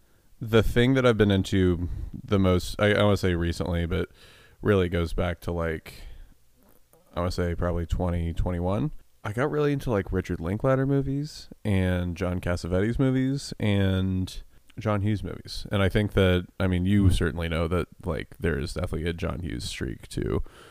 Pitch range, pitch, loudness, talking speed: 85-105 Hz, 95 Hz, -26 LUFS, 185 wpm